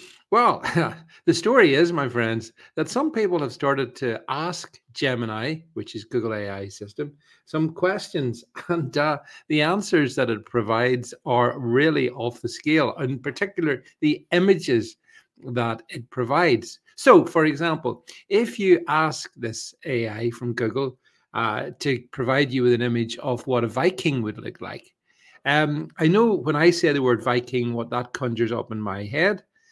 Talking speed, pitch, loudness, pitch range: 160 wpm, 140 Hz, -23 LUFS, 120-170 Hz